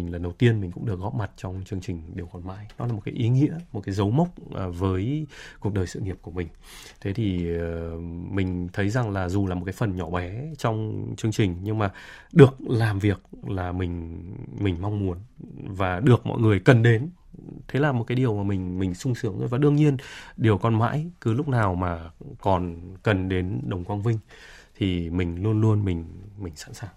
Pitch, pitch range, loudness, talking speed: 100 Hz, 90-120 Hz, -25 LUFS, 220 wpm